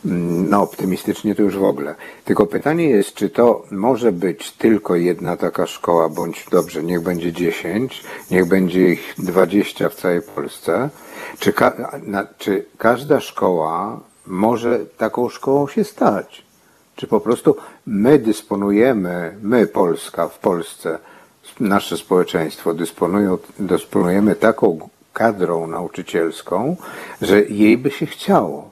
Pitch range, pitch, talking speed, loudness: 90-105 Hz, 95 Hz, 125 wpm, -18 LUFS